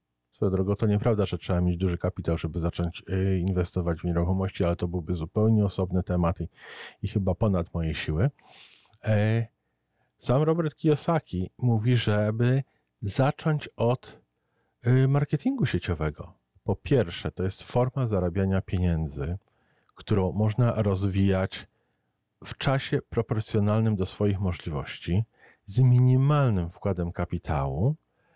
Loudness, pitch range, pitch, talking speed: -27 LUFS, 90-115 Hz, 95 Hz, 110 wpm